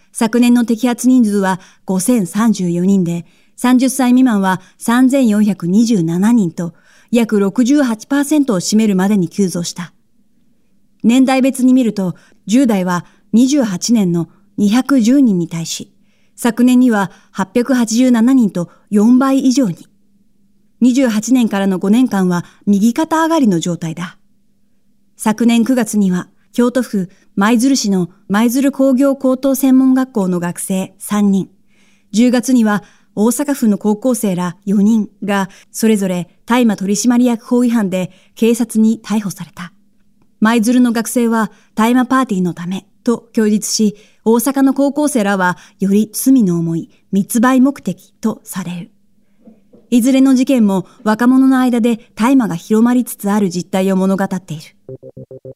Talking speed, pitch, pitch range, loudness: 220 characters per minute, 215 Hz, 195-245 Hz, -14 LUFS